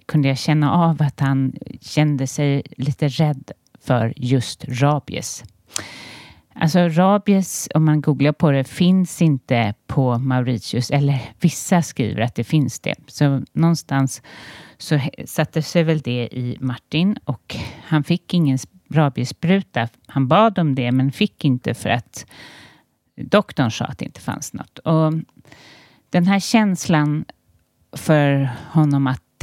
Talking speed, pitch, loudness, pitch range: 140 wpm, 145 Hz, -19 LUFS, 130-160 Hz